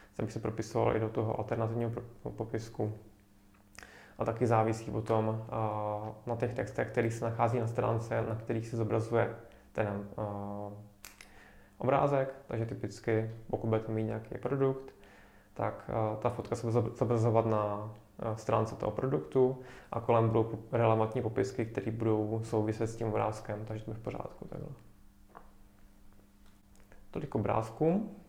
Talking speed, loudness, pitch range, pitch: 130 wpm, -33 LUFS, 105-115 Hz, 110 Hz